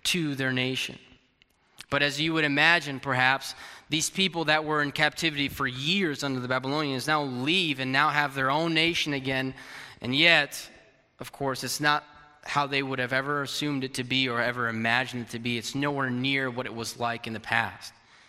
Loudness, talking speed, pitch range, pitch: -26 LUFS, 195 wpm, 130-150 Hz, 135 Hz